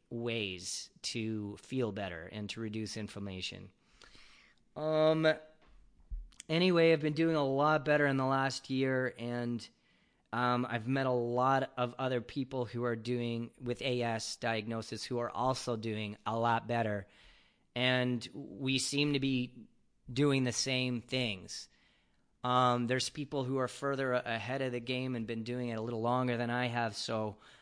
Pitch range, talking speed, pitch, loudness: 115-130 Hz, 155 wpm, 125 Hz, -34 LUFS